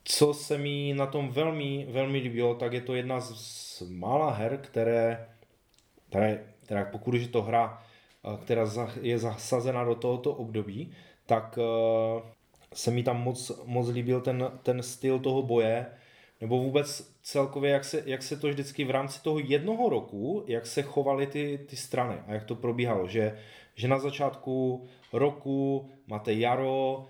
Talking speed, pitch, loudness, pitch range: 155 wpm, 125 Hz, -30 LUFS, 115-140 Hz